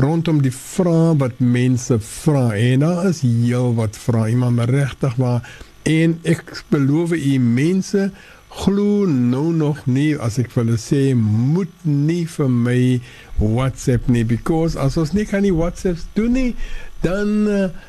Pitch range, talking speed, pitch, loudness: 125-170 Hz, 150 wpm, 140 Hz, -18 LUFS